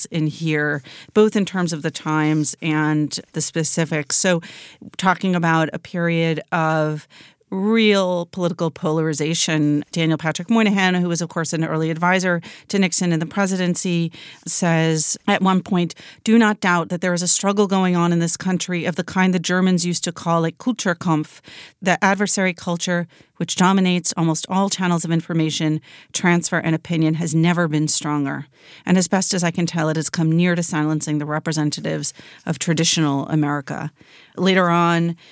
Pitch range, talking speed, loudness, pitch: 160-185 Hz, 170 wpm, -19 LUFS, 170 Hz